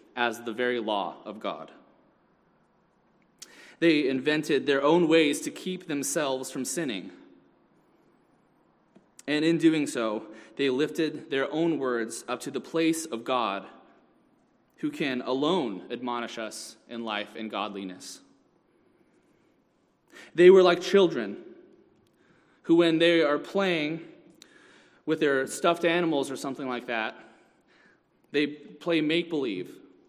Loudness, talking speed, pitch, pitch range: -27 LUFS, 120 wpm, 145 Hz, 120-165 Hz